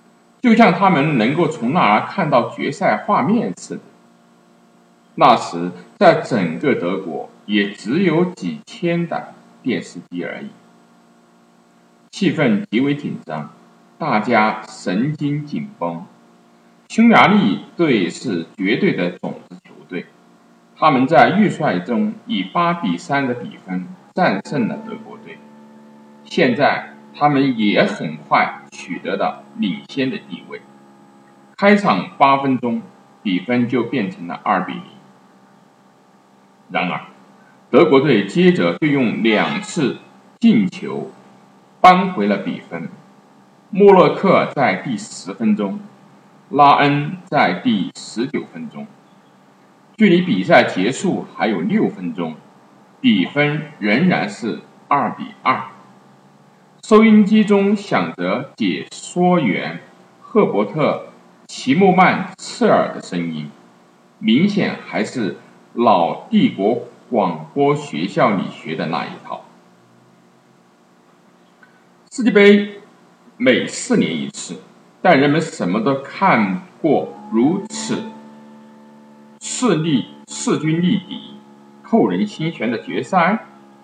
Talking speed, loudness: 165 characters per minute, -17 LUFS